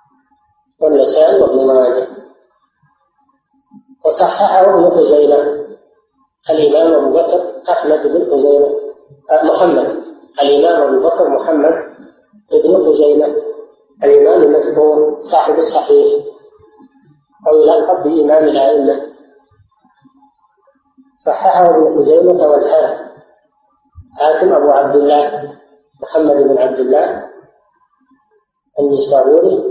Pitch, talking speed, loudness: 210 Hz, 80 wpm, -11 LUFS